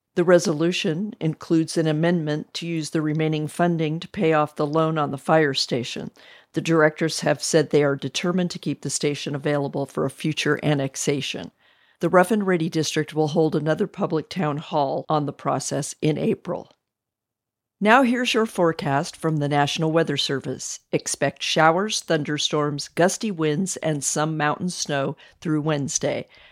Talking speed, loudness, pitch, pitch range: 160 wpm, -23 LUFS, 155 Hz, 145-170 Hz